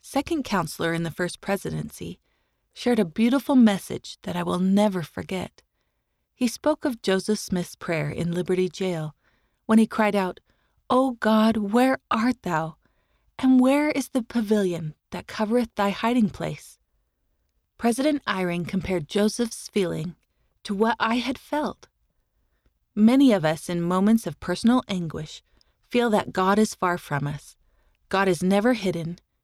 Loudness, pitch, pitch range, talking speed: -24 LUFS, 200 Hz, 175-235 Hz, 150 wpm